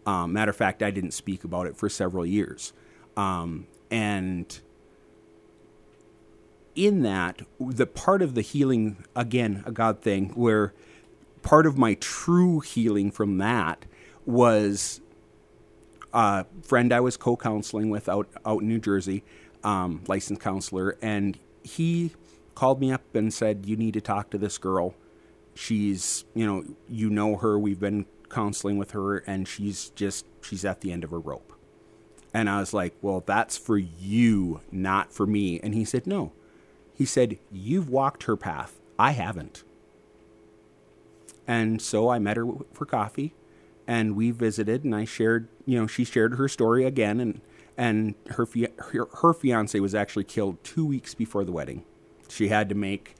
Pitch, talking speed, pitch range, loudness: 110 Hz, 165 wpm, 100-120 Hz, -26 LUFS